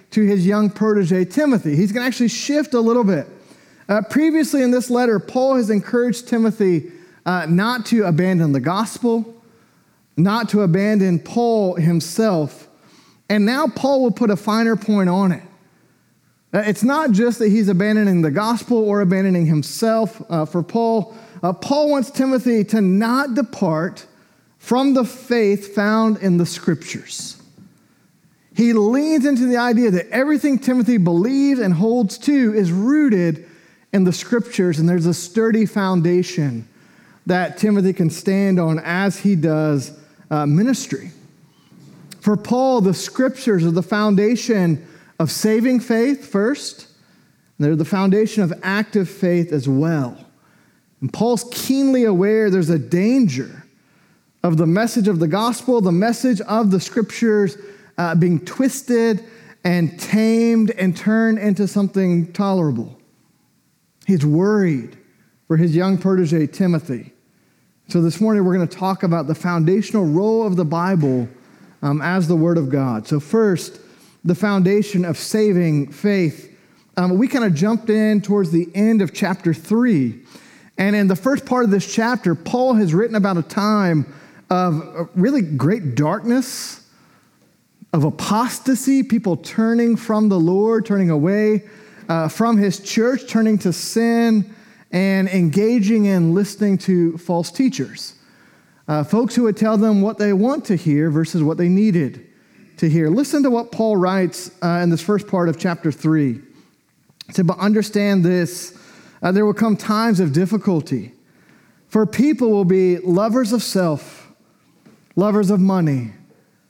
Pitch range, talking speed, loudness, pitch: 175-225 Hz, 150 wpm, -18 LUFS, 200 Hz